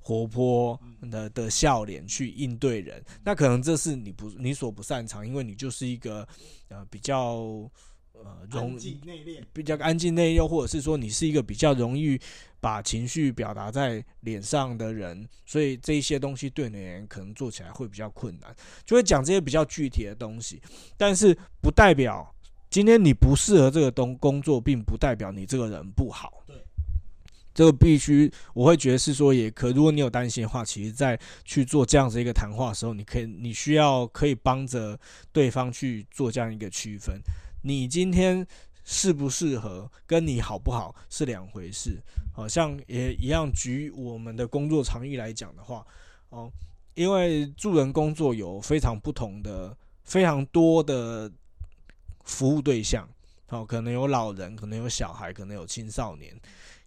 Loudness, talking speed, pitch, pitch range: -25 LUFS, 265 characters per minute, 125 Hz, 105-145 Hz